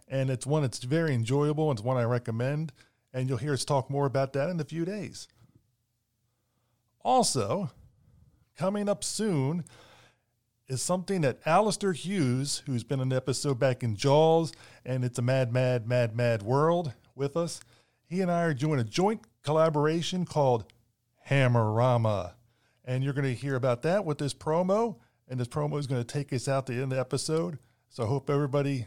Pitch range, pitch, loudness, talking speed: 120-155 Hz, 135 Hz, -29 LUFS, 185 wpm